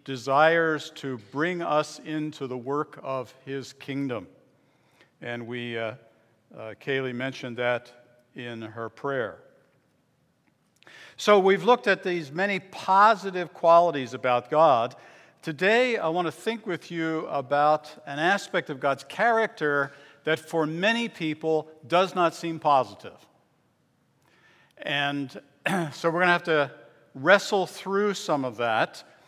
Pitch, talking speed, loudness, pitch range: 155 Hz, 130 wpm, -25 LUFS, 135-175 Hz